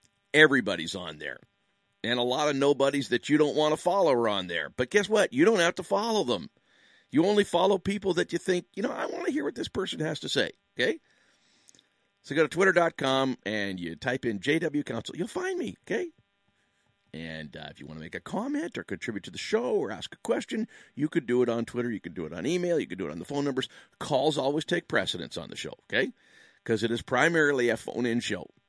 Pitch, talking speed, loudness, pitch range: 145 Hz, 240 wpm, -28 LUFS, 115-185 Hz